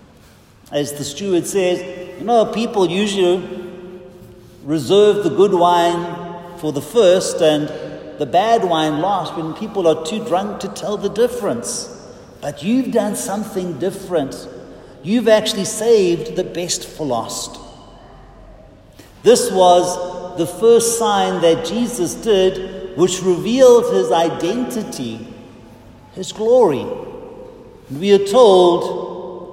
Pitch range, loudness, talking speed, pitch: 165-210 Hz, -16 LUFS, 120 wpm, 180 Hz